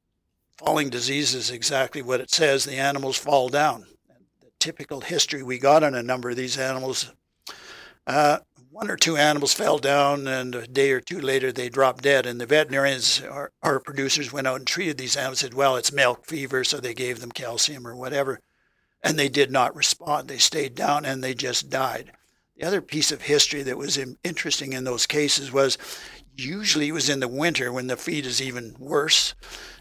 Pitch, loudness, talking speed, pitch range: 135 Hz, -23 LUFS, 195 wpm, 130-145 Hz